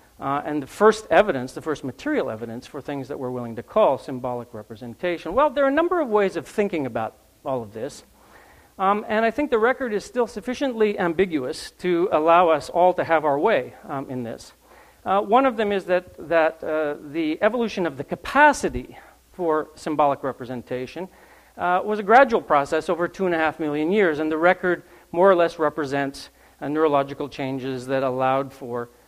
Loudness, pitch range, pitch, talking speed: -22 LUFS, 135-195 Hz, 160 Hz, 190 wpm